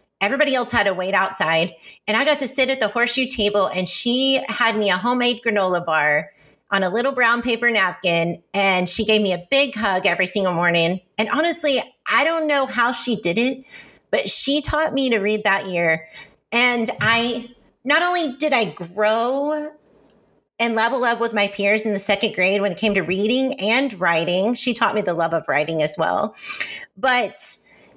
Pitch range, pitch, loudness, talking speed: 185-250 Hz, 220 Hz, -19 LUFS, 195 wpm